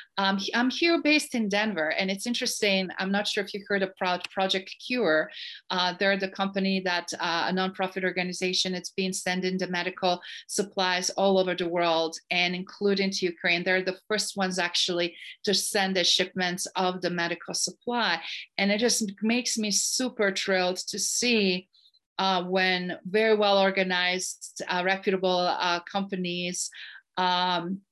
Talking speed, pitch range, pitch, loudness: 155 wpm, 180-200 Hz, 190 Hz, -26 LUFS